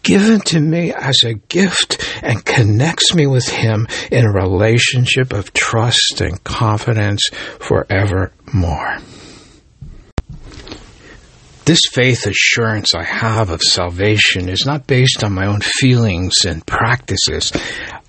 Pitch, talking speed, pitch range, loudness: 110 Hz, 115 wpm, 100-130 Hz, -14 LUFS